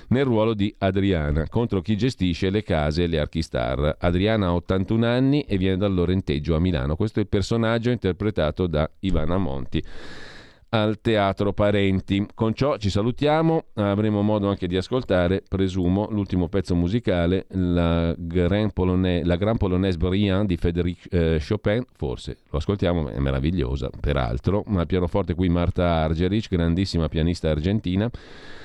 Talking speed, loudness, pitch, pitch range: 145 wpm, -23 LUFS, 95 Hz, 85-105 Hz